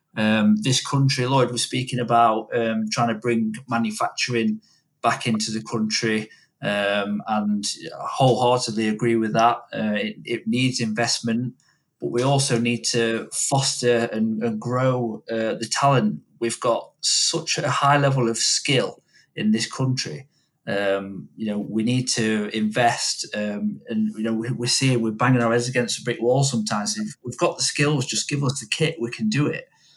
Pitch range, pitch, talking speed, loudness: 110-130 Hz, 115 Hz, 175 wpm, -22 LUFS